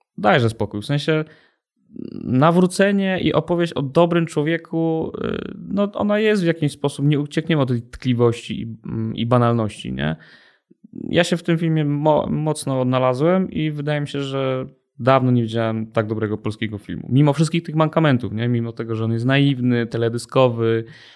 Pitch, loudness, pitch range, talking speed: 140 Hz, -20 LUFS, 115-165 Hz, 150 wpm